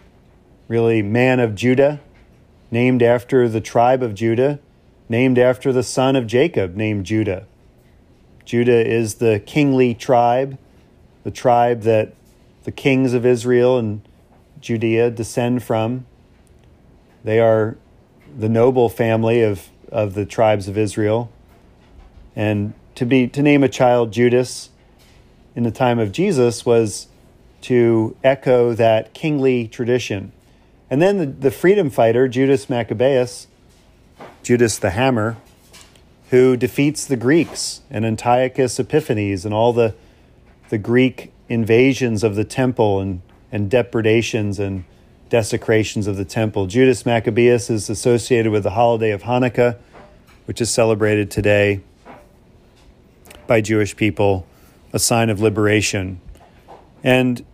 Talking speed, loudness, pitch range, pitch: 125 wpm, -17 LUFS, 105-125 Hz, 115 Hz